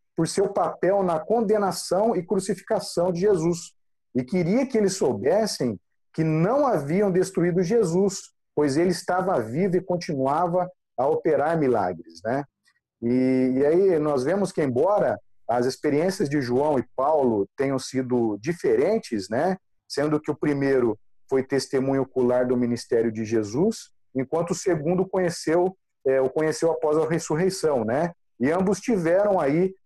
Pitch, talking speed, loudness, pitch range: 165 Hz, 145 wpm, -24 LUFS, 130-190 Hz